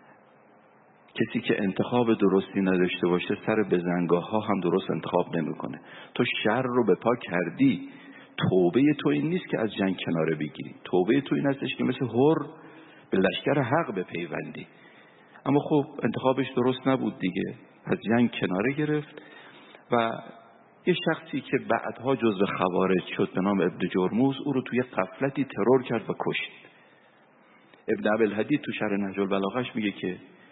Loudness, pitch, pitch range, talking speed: -27 LUFS, 115 Hz, 100-140 Hz, 155 wpm